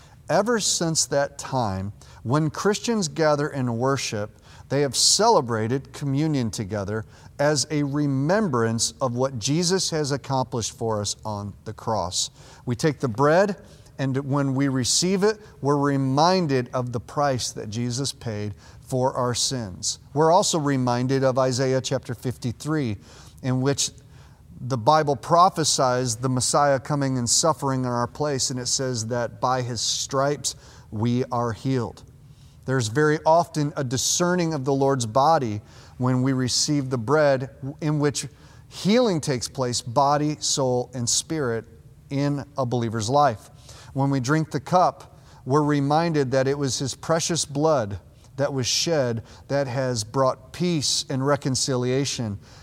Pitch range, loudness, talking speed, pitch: 120-145 Hz, -23 LUFS, 145 wpm, 135 Hz